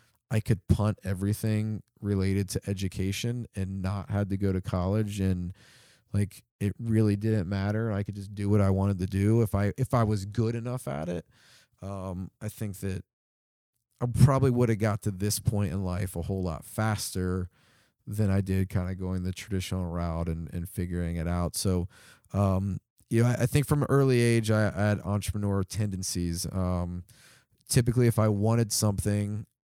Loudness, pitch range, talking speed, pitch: -29 LUFS, 95-110 Hz, 185 wpm, 100 Hz